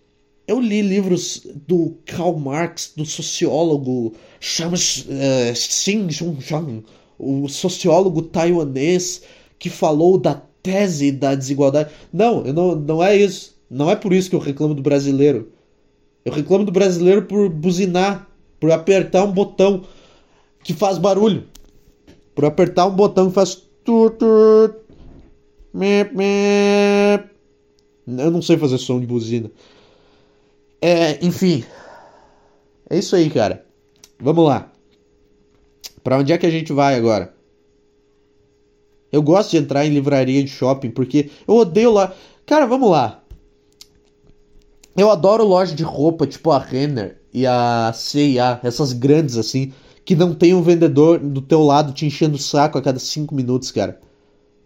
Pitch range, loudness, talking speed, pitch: 135-185 Hz, -17 LUFS, 130 wpm, 155 Hz